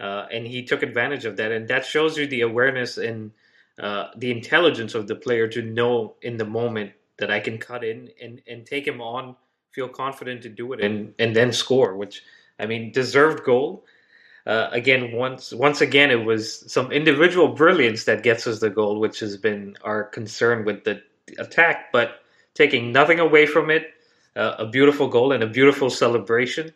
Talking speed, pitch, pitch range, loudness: 195 wpm, 120 Hz, 110-135 Hz, -21 LUFS